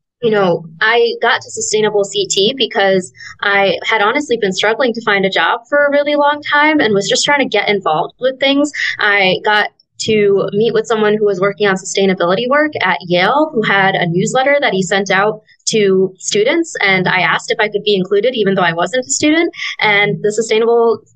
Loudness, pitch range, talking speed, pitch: -13 LUFS, 195-250 Hz, 205 wpm, 210 Hz